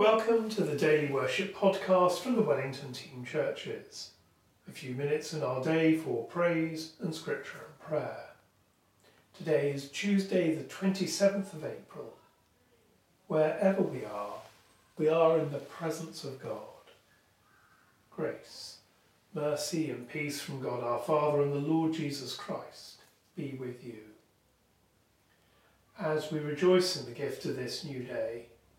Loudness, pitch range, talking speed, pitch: -32 LUFS, 135-180 Hz, 140 wpm, 155 Hz